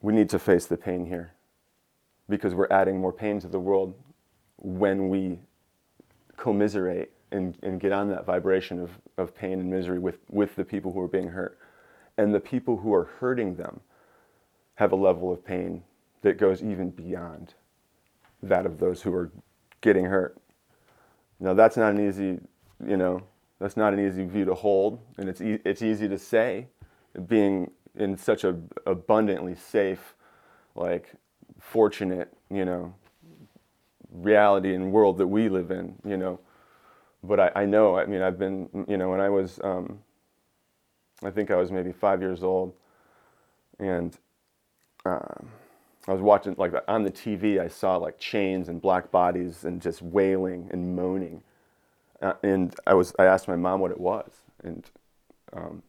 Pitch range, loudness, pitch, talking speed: 90-100 Hz, -26 LUFS, 95 Hz, 170 wpm